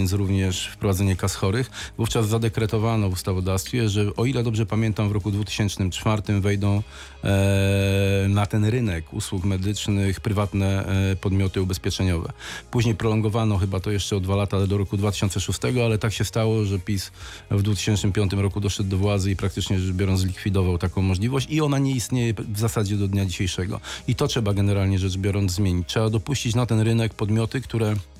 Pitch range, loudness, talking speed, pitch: 95-110 Hz, -23 LUFS, 170 wpm, 100 Hz